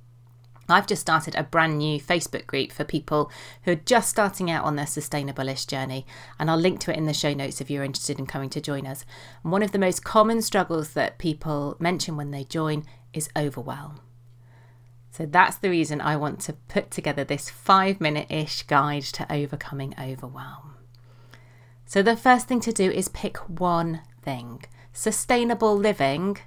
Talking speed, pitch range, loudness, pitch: 185 wpm, 135-175 Hz, -25 LUFS, 150 Hz